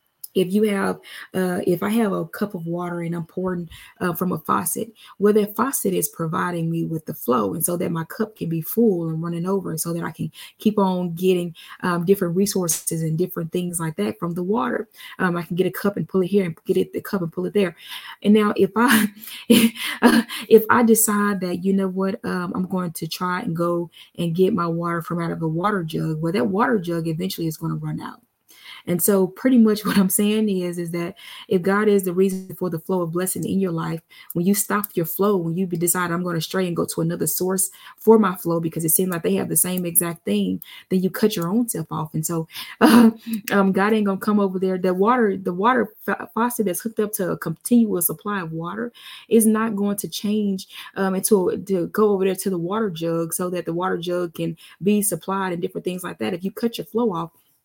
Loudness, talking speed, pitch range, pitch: -21 LUFS, 240 wpm, 170-210 Hz, 185 Hz